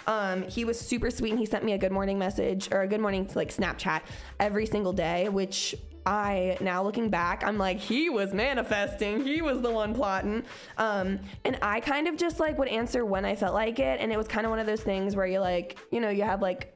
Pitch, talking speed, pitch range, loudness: 205 Hz, 245 wpm, 190-225 Hz, -29 LUFS